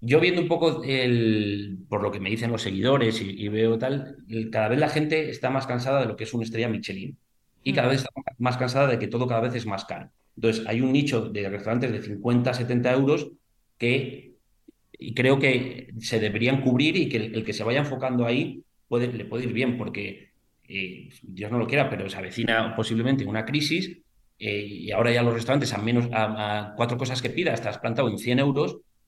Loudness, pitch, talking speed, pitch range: -25 LUFS, 120 Hz, 220 wpm, 110-130 Hz